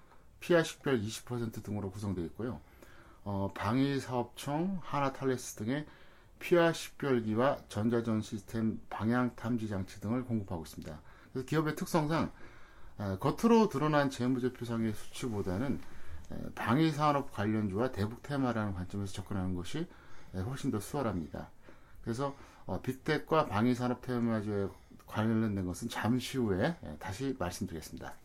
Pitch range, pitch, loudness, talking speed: 100-135 Hz, 115 Hz, -34 LUFS, 320 characters per minute